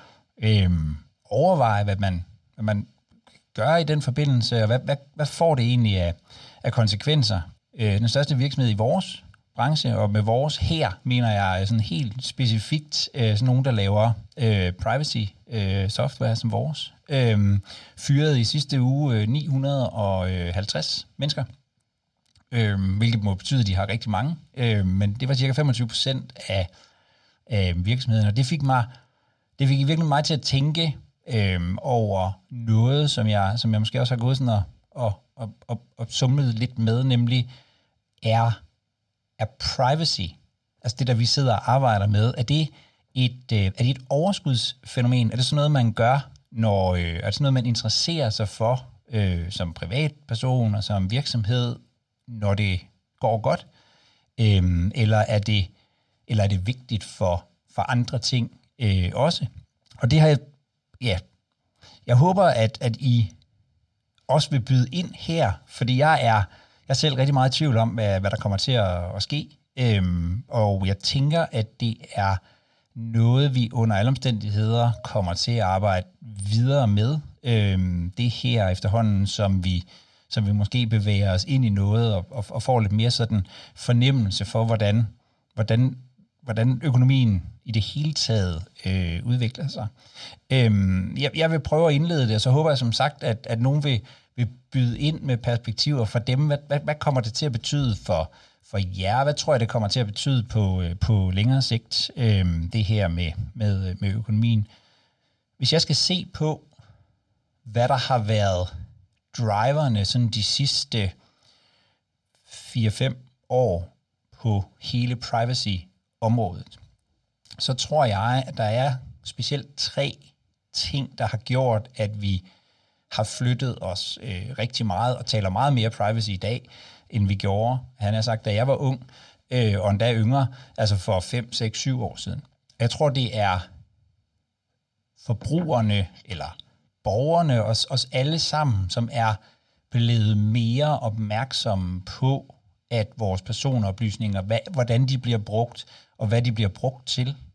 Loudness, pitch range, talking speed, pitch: -23 LUFS, 105-130 Hz, 160 wpm, 115 Hz